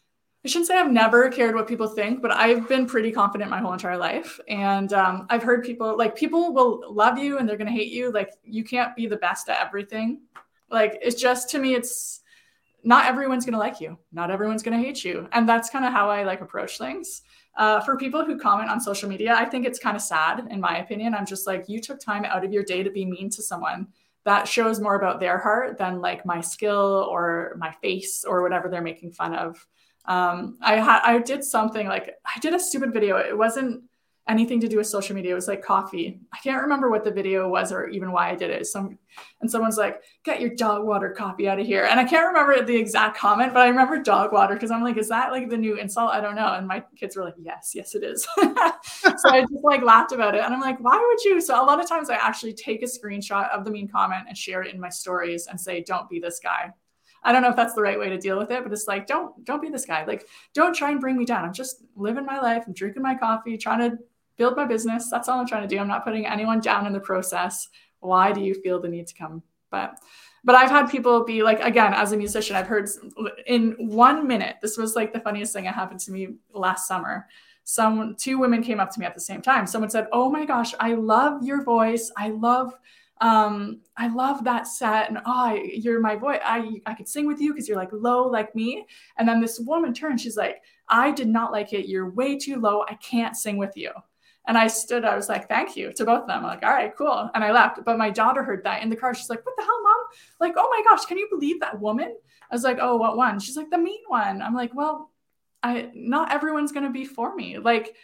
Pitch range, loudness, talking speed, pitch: 205-255 Hz, -23 LUFS, 255 wpm, 225 Hz